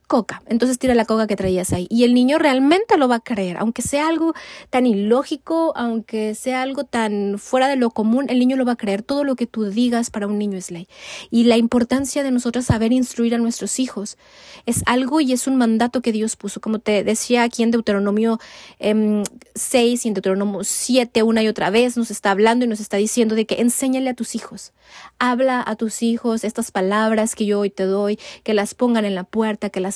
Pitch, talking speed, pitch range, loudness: 230 Hz, 220 wpm, 210-250 Hz, -19 LUFS